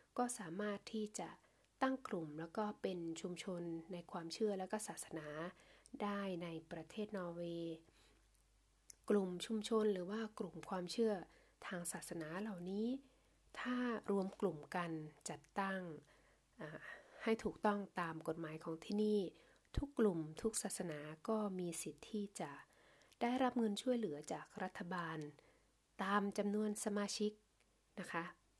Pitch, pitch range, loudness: 195 Hz, 170-215 Hz, -43 LUFS